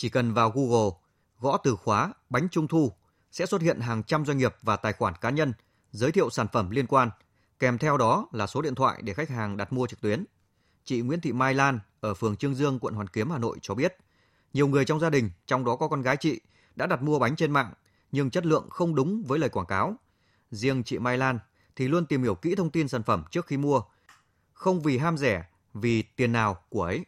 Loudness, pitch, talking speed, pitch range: -27 LUFS, 125 Hz, 240 wpm, 110-145 Hz